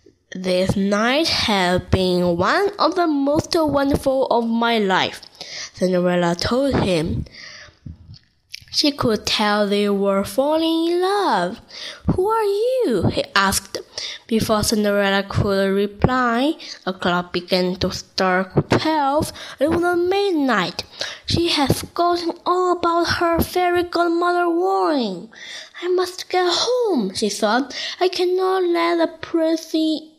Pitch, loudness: 295 Hz, -19 LUFS